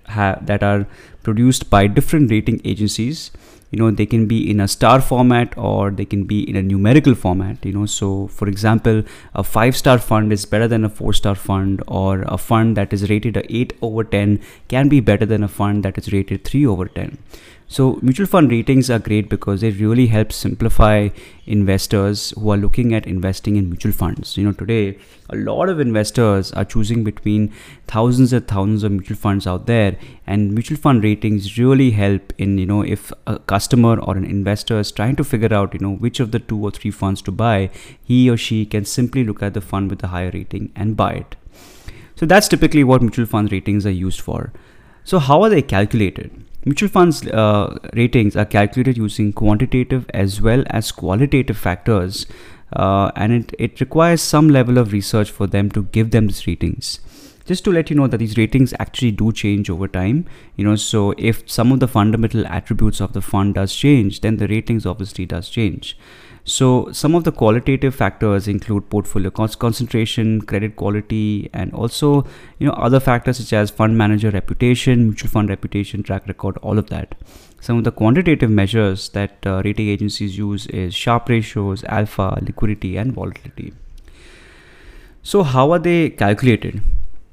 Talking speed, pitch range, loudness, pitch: 190 wpm, 100-120 Hz, -17 LUFS, 105 Hz